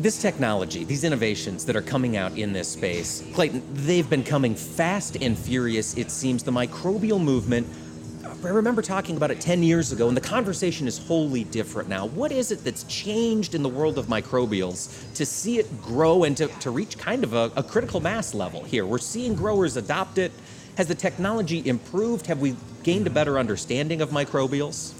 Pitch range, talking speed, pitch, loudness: 125-185 Hz, 195 wpm, 145 Hz, -25 LUFS